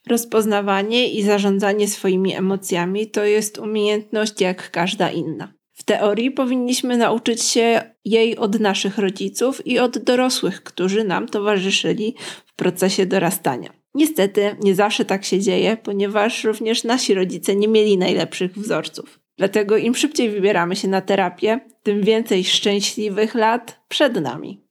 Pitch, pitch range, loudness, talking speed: 210 Hz, 195-225 Hz, -19 LUFS, 135 wpm